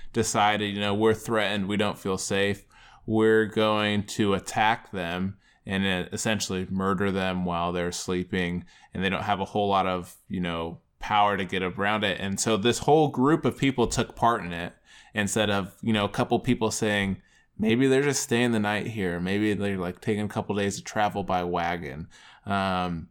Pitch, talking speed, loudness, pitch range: 100 Hz, 190 wpm, -26 LUFS, 95-110 Hz